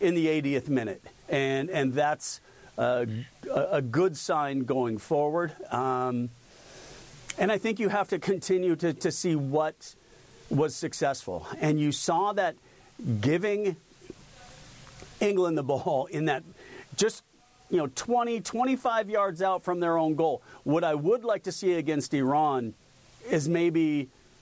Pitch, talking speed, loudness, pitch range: 160 Hz, 145 wpm, -28 LUFS, 135-185 Hz